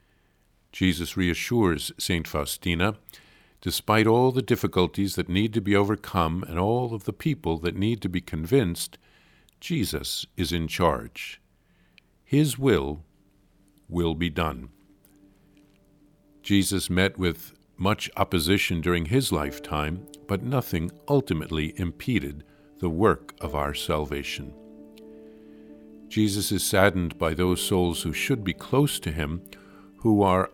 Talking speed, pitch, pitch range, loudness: 125 wpm, 90 Hz, 80-100 Hz, -26 LUFS